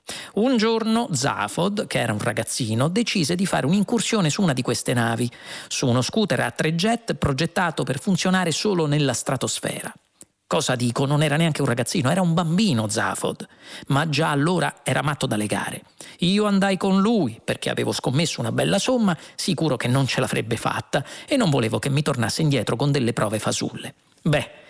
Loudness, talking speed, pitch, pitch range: -22 LUFS, 180 wpm, 155 Hz, 130-195 Hz